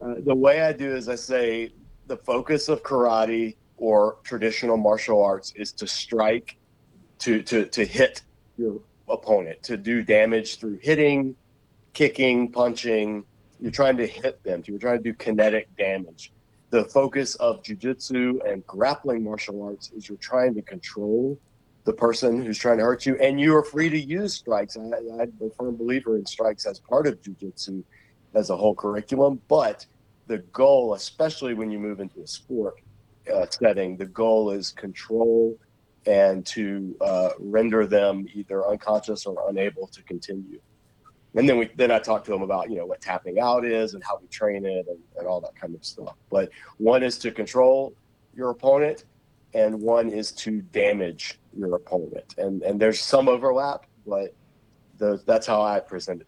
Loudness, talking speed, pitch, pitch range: -24 LUFS, 175 wpm, 115 Hz, 105-130 Hz